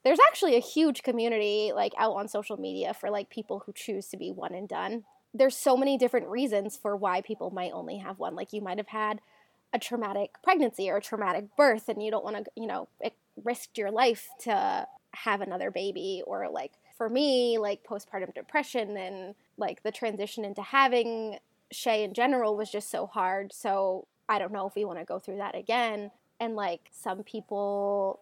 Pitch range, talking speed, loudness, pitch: 200-245 Hz, 200 wpm, -30 LUFS, 215 Hz